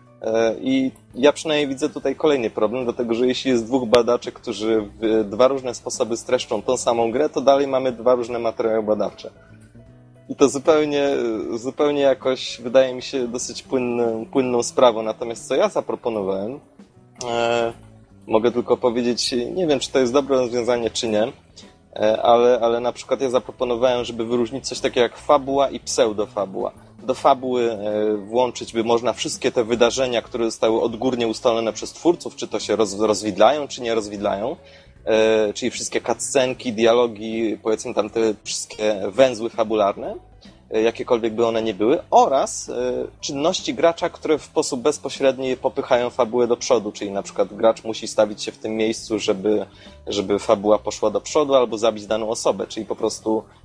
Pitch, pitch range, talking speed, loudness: 120 Hz, 110-130 Hz, 160 wpm, -21 LUFS